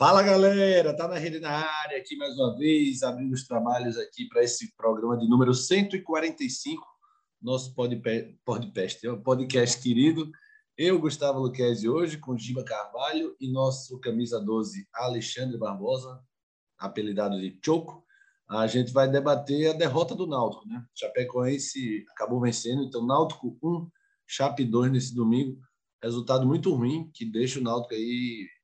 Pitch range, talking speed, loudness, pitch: 120-170 Hz, 145 wpm, -27 LUFS, 130 Hz